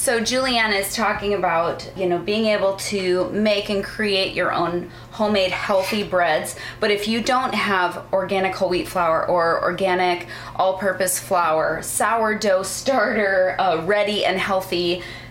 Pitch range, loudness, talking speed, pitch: 180-210 Hz, -20 LUFS, 145 wpm, 195 Hz